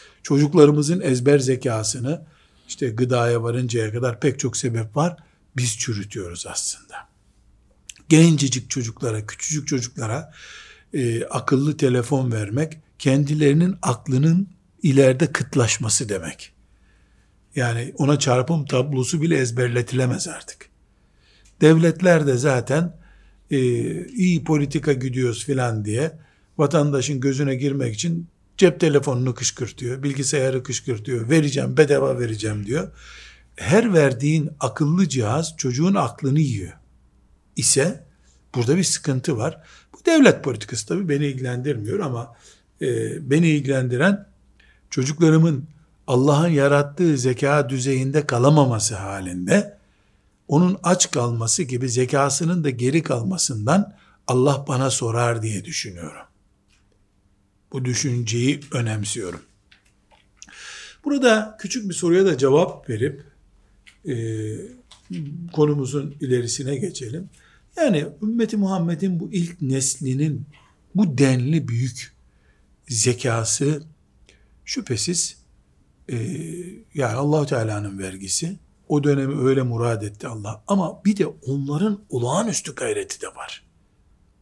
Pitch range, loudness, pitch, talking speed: 120-160 Hz, -21 LUFS, 140 Hz, 100 wpm